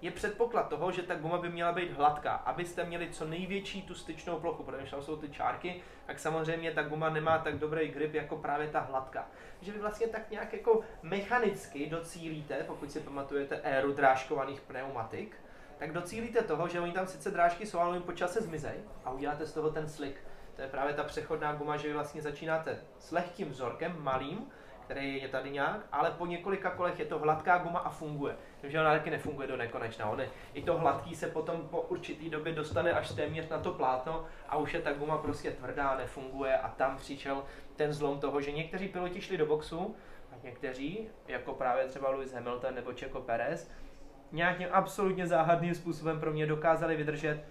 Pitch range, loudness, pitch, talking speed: 140-175 Hz, -35 LUFS, 155 Hz, 195 wpm